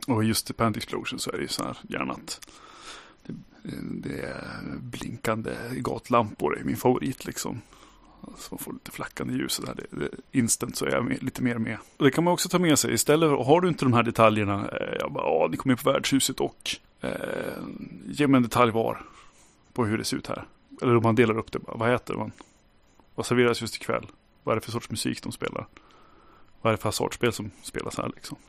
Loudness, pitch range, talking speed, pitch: -26 LUFS, 110-135 Hz, 220 wpm, 120 Hz